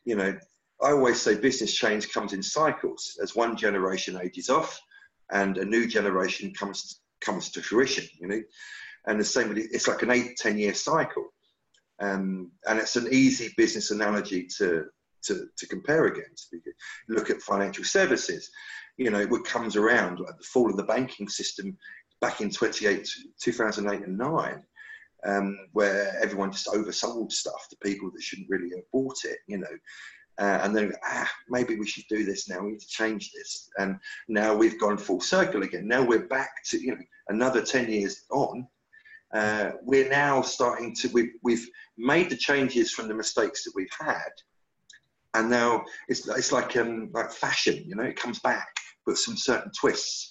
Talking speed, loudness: 180 wpm, -27 LUFS